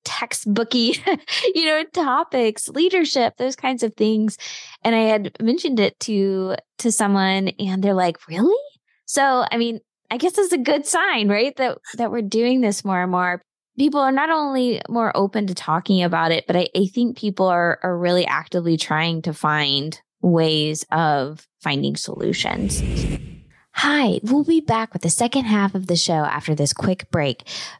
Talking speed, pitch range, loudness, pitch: 175 wpm, 180-255 Hz, -20 LUFS, 215 Hz